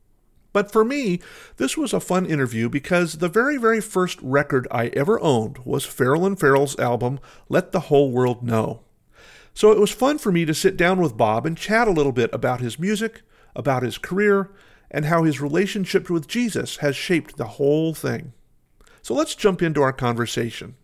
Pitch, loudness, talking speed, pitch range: 160 Hz, -21 LUFS, 190 wpm, 135-195 Hz